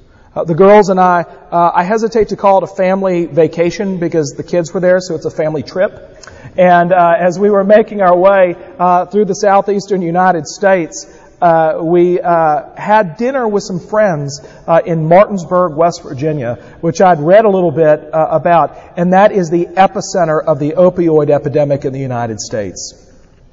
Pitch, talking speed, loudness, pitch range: 175 Hz, 185 wpm, -12 LUFS, 160-195 Hz